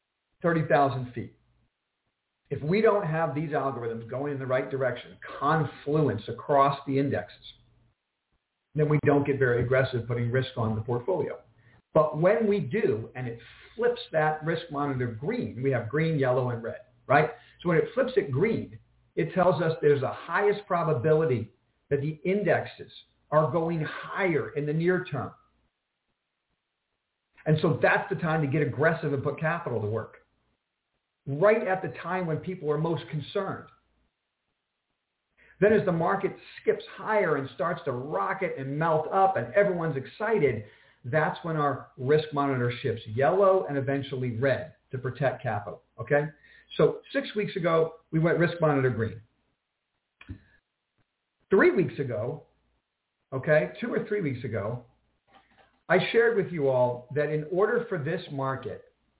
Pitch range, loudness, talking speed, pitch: 125-170 Hz, -27 LUFS, 150 wpm, 150 Hz